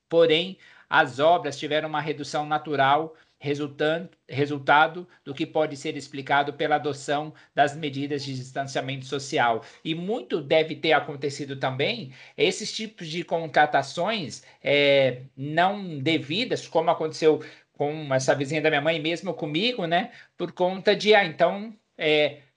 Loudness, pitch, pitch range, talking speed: -25 LUFS, 155 Hz, 145-170 Hz, 135 wpm